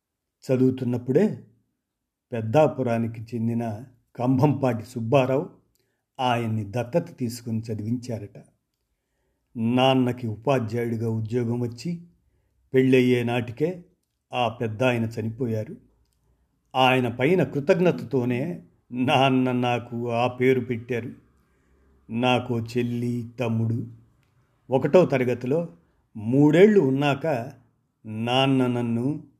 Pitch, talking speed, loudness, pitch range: 125 Hz, 75 wpm, -24 LUFS, 115-130 Hz